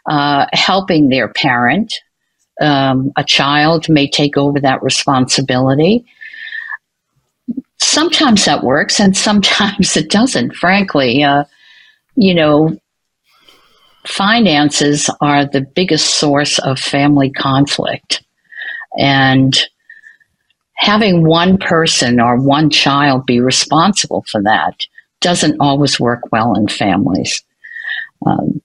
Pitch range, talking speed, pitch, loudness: 140-210 Hz, 105 wpm, 155 Hz, -12 LUFS